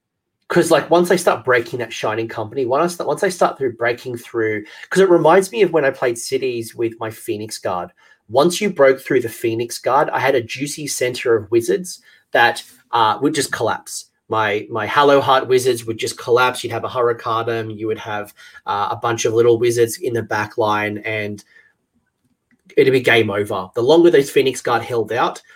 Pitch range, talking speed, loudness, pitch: 110-180 Hz, 205 wpm, -18 LUFS, 125 Hz